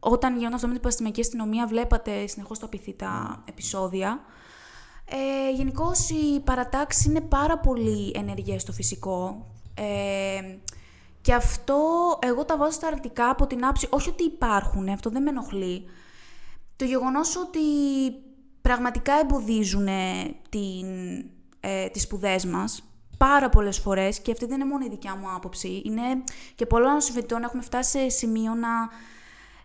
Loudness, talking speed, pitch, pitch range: -26 LUFS, 140 wpm, 235 Hz, 195-270 Hz